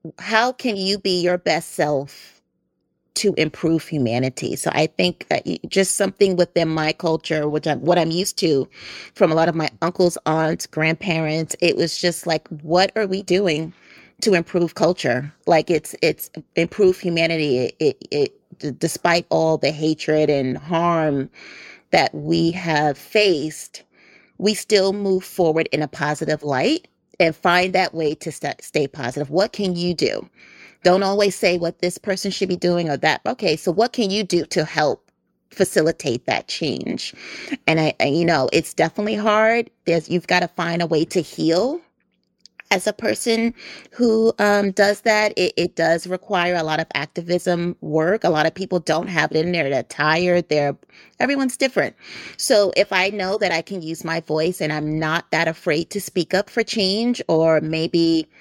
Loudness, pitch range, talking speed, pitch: -20 LUFS, 155-195 Hz, 180 wpm, 170 Hz